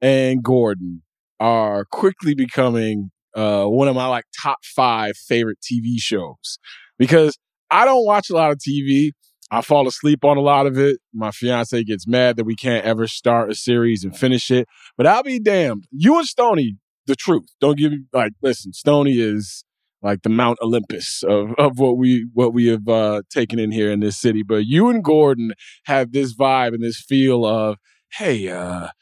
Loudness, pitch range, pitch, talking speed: -18 LUFS, 110-140 Hz, 120 Hz, 190 wpm